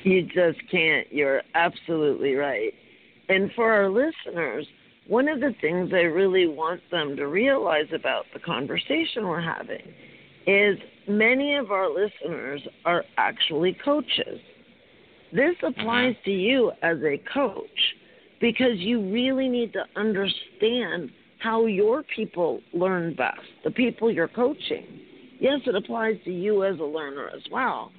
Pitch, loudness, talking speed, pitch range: 215 Hz, -24 LUFS, 140 wpm, 180-250 Hz